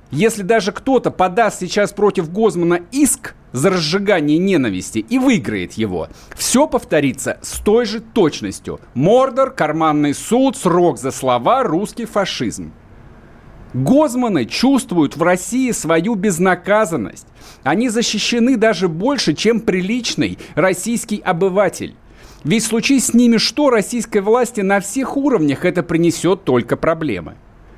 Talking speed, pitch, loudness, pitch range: 120 wpm, 205 Hz, -16 LUFS, 170-235 Hz